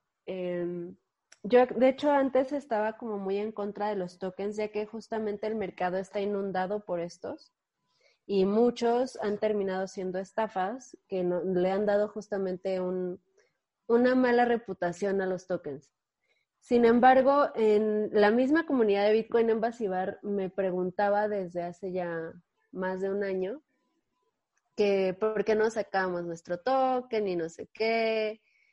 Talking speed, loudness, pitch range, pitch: 145 wpm, -29 LUFS, 185-230 Hz, 205 Hz